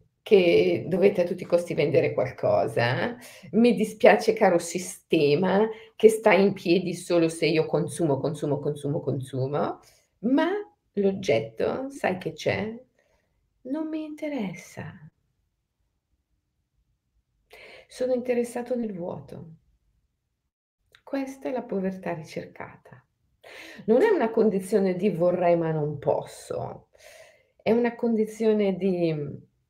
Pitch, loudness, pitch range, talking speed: 190 Hz, -25 LUFS, 160-230 Hz, 105 wpm